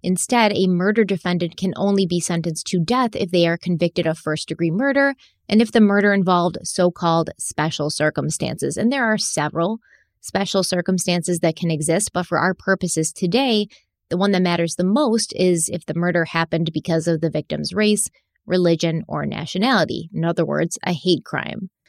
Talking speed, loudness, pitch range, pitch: 180 wpm, -20 LUFS, 165-200 Hz, 180 Hz